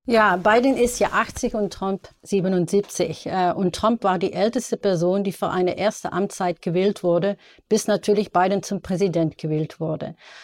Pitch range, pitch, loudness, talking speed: 180-210 Hz, 195 Hz, -22 LUFS, 160 wpm